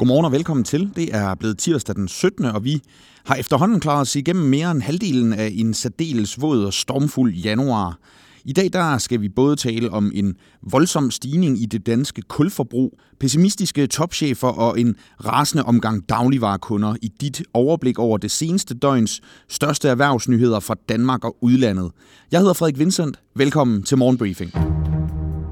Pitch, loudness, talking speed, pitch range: 125 Hz, -19 LUFS, 160 wpm, 110-145 Hz